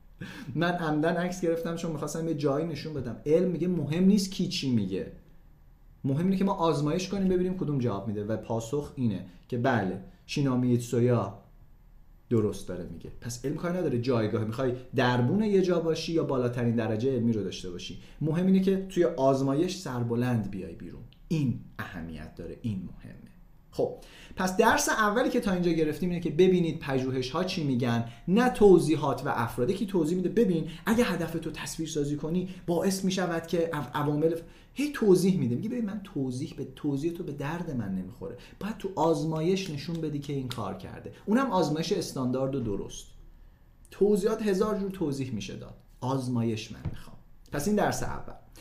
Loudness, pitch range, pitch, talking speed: -28 LUFS, 120-180 Hz, 150 Hz, 175 wpm